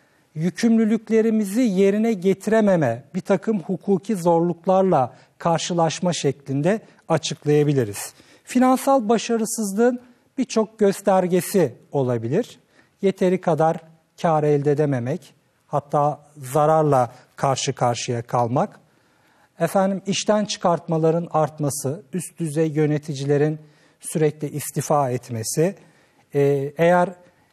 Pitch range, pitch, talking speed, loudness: 145-195 Hz, 165 Hz, 80 wpm, -21 LUFS